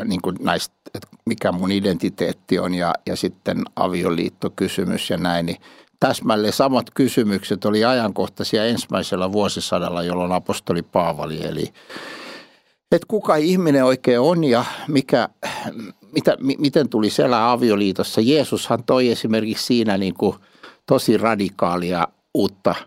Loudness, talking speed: -20 LUFS, 125 wpm